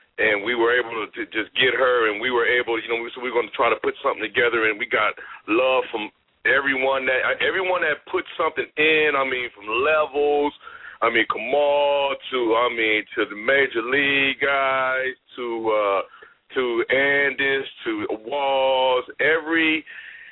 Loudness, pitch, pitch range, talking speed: -21 LUFS, 140 Hz, 130-165 Hz, 170 wpm